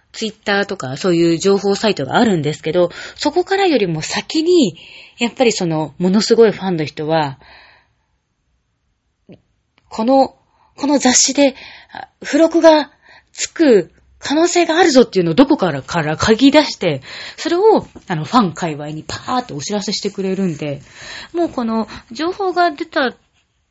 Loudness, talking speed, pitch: -15 LUFS, 305 characters per minute, 220 Hz